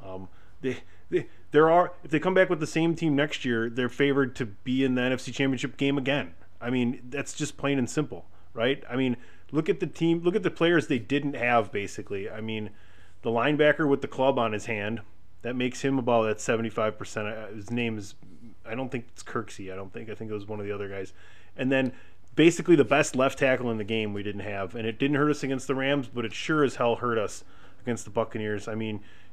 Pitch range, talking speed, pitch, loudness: 105-140 Hz, 240 wpm, 120 Hz, -27 LUFS